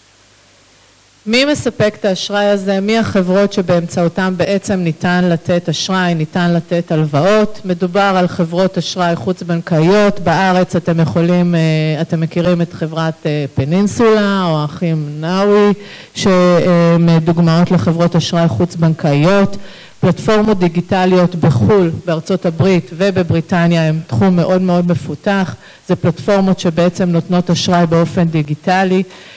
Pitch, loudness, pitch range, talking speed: 175 Hz, -13 LUFS, 165-190 Hz, 110 wpm